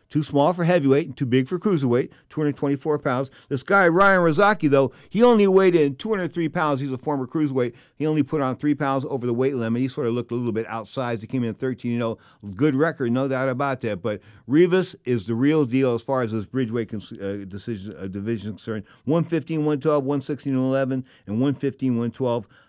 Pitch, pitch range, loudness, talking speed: 135 Hz, 120-150 Hz, -23 LUFS, 210 wpm